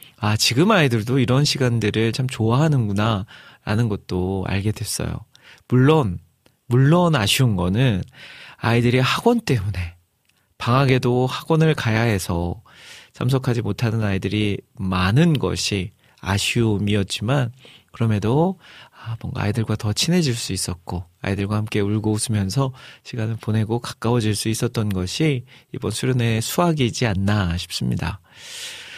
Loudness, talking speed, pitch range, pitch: -21 LUFS, 295 characters per minute, 100-130 Hz, 115 Hz